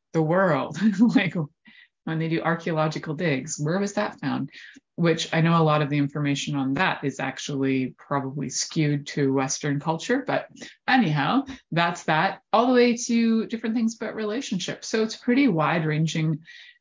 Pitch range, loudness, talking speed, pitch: 150-220 Hz, -24 LUFS, 165 wpm, 165 Hz